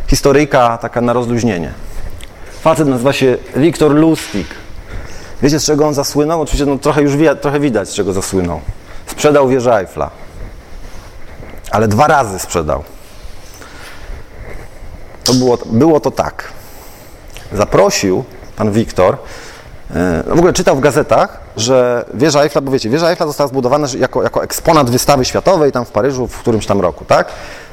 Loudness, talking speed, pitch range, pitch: -13 LUFS, 145 wpm, 105-145 Hz, 125 Hz